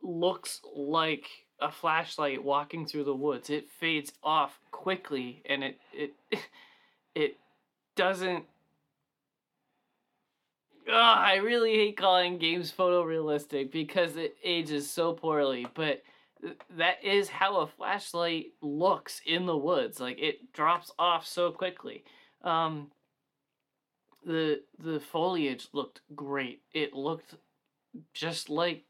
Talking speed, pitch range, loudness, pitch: 115 wpm, 145-180 Hz, -30 LUFS, 165 Hz